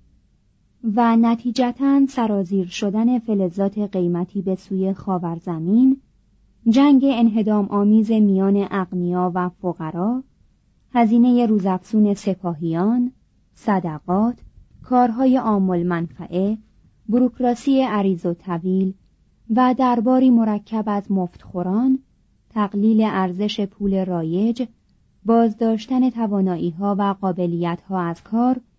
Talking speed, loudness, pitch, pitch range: 95 wpm, -20 LUFS, 205 Hz, 185-235 Hz